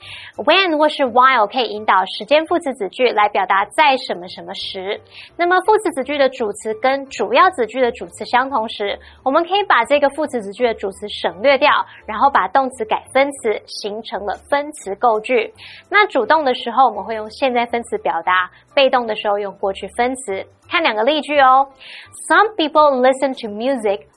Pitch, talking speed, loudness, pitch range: 250 Hz, 340 characters per minute, -17 LUFS, 210-285 Hz